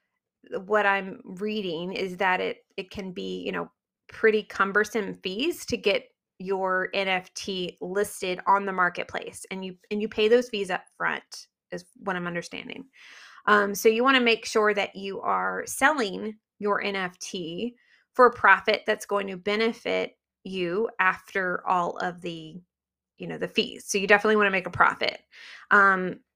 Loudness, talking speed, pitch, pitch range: -25 LUFS, 165 wpm, 200 Hz, 185-220 Hz